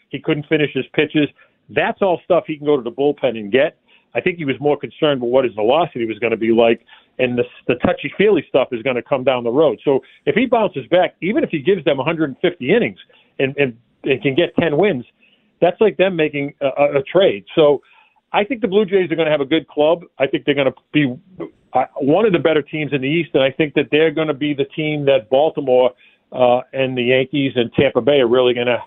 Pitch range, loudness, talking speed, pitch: 130-165 Hz, -17 LUFS, 250 wpm, 145 Hz